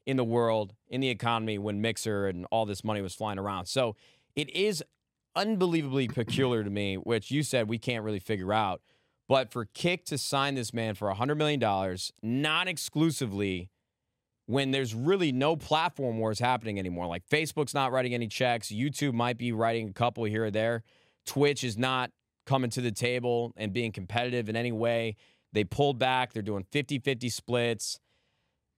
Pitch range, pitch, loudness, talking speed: 110-135 Hz, 120 Hz, -30 LUFS, 180 wpm